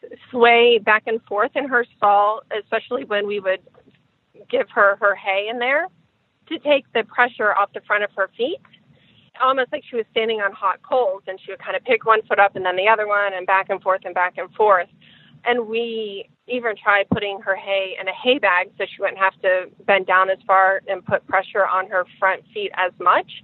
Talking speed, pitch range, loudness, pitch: 220 wpm, 190-235 Hz, -19 LUFS, 205 Hz